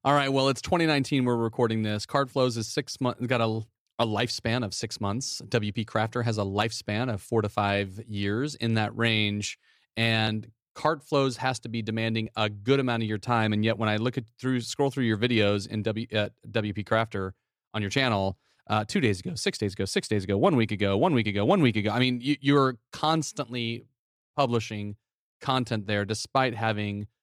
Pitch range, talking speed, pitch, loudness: 105-125 Hz, 205 wpm, 115 Hz, -27 LUFS